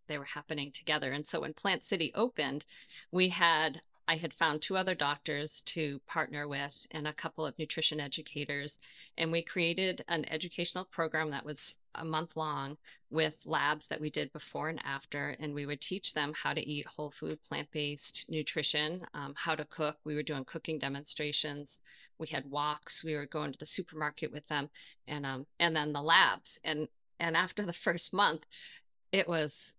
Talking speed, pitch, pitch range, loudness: 185 wpm, 155 Hz, 145-165 Hz, -34 LUFS